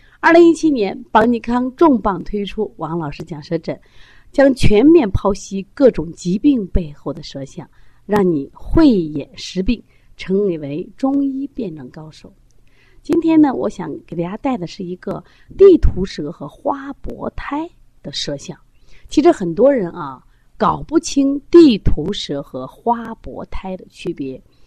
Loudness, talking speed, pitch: -16 LUFS, 215 characters per minute, 200 Hz